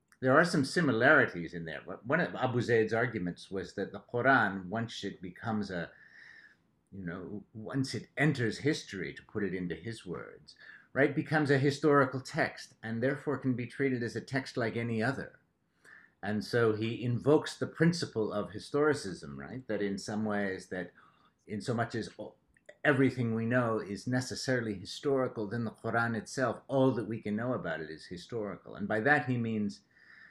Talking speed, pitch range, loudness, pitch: 175 wpm, 105-130 Hz, -32 LUFS, 115 Hz